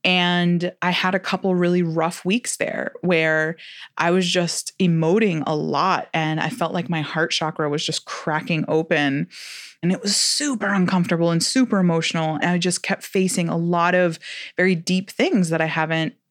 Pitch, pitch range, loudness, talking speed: 175 Hz, 160-185 Hz, -21 LUFS, 180 wpm